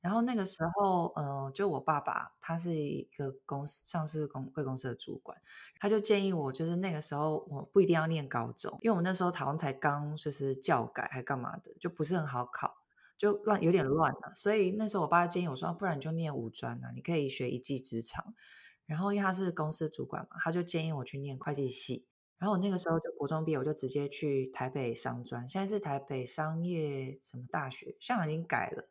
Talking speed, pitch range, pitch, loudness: 340 characters per minute, 140-180 Hz, 155 Hz, -34 LUFS